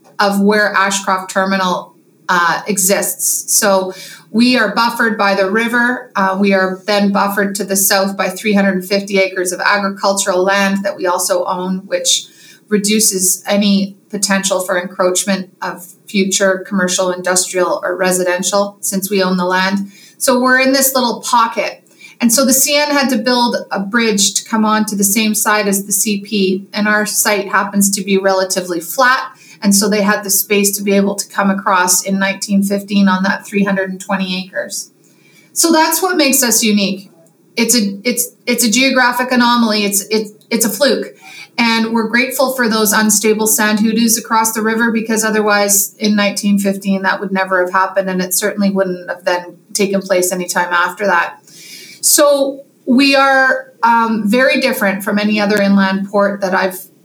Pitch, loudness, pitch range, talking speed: 200 Hz, -13 LUFS, 190-225 Hz, 170 wpm